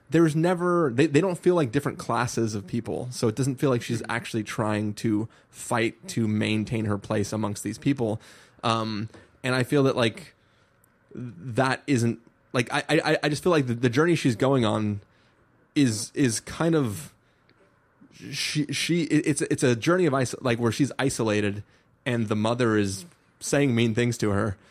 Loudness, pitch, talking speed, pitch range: -25 LUFS, 120 Hz, 180 wpm, 110-145 Hz